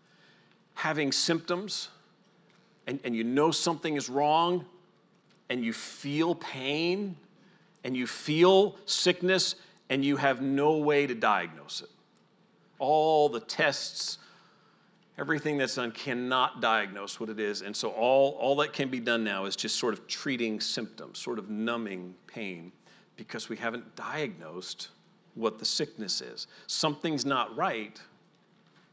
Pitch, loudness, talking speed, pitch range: 140 Hz, -29 LUFS, 135 wpm, 120-170 Hz